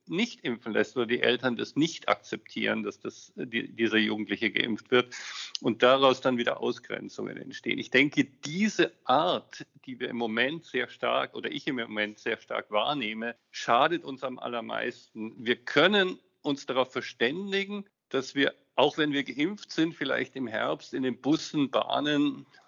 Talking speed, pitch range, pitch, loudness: 165 wpm, 120-160 Hz, 135 Hz, -28 LUFS